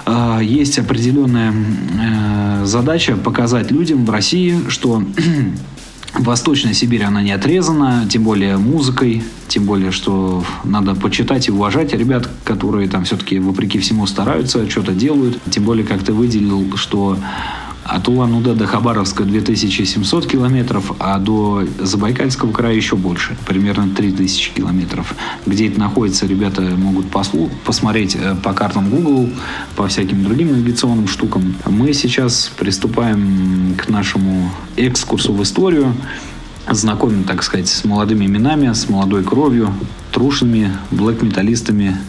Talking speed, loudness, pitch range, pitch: 125 wpm, -15 LUFS, 95-120 Hz, 105 Hz